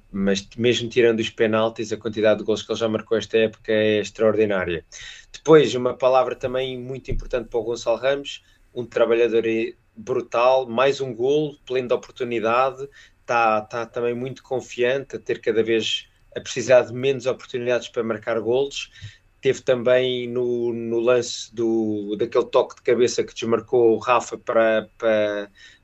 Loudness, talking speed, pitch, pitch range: -22 LUFS, 160 wpm, 120 Hz, 110-125 Hz